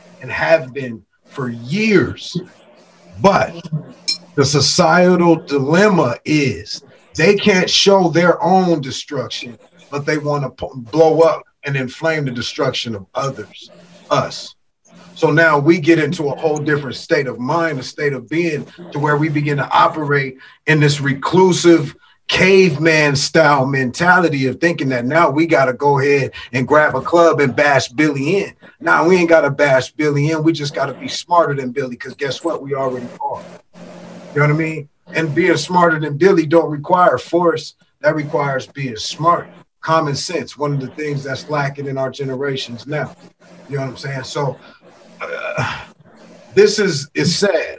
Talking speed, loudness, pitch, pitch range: 170 wpm, -16 LUFS, 150 Hz, 140-170 Hz